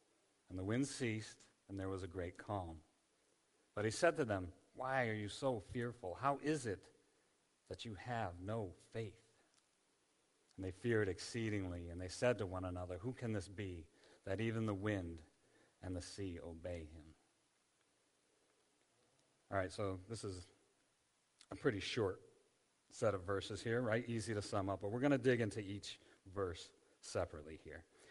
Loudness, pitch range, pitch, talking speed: -43 LUFS, 95-120 Hz, 105 Hz, 165 wpm